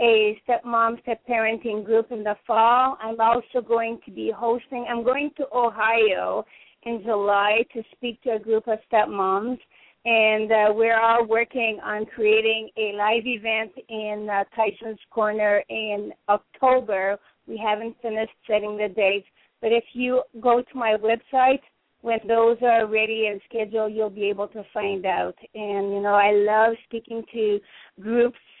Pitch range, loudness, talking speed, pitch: 210-235 Hz, -23 LUFS, 165 wpm, 225 Hz